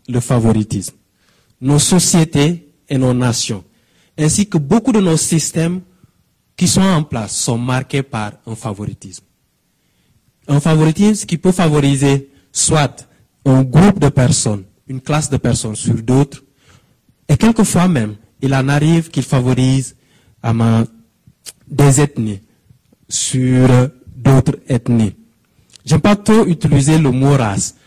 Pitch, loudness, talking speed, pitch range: 135 Hz, -14 LUFS, 125 wpm, 120-155 Hz